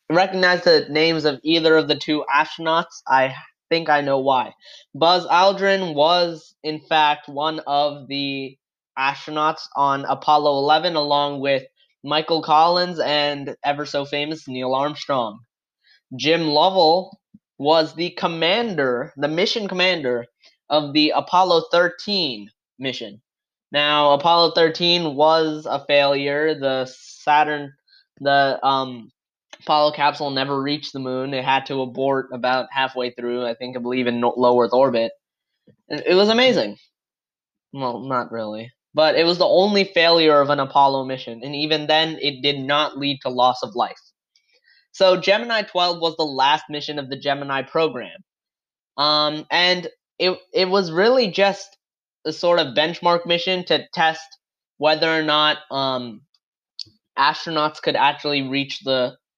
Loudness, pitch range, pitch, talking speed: -19 LUFS, 135-170 Hz, 150 Hz, 140 wpm